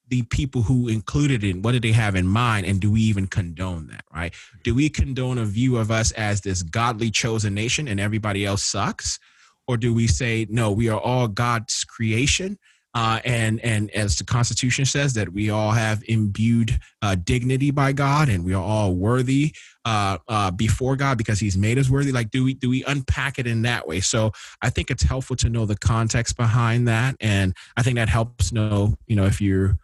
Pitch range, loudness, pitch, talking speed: 105-125 Hz, -22 LUFS, 115 Hz, 210 wpm